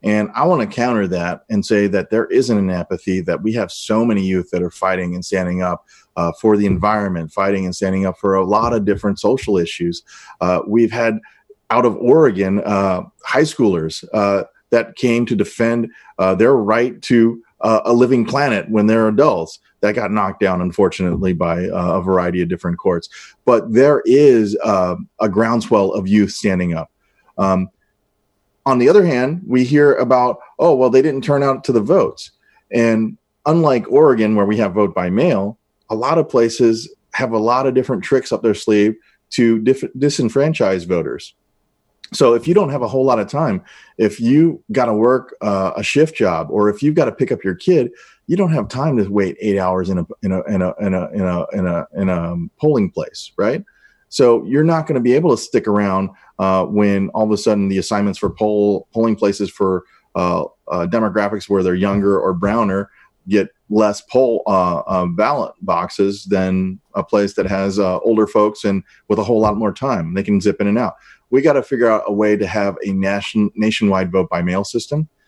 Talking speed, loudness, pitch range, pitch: 195 wpm, -16 LUFS, 95-115 Hz, 105 Hz